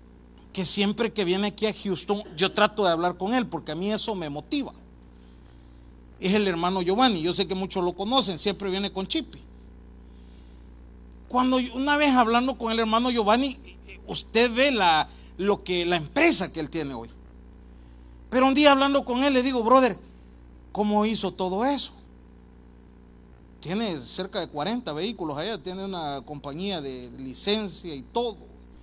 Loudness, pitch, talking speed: -23 LUFS, 190 Hz, 160 wpm